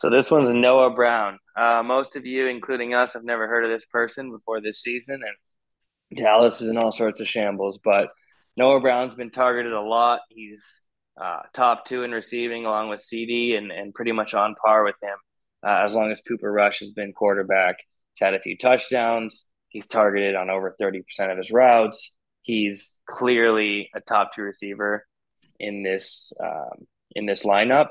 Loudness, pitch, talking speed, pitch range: -22 LUFS, 115 Hz, 185 wpm, 105-120 Hz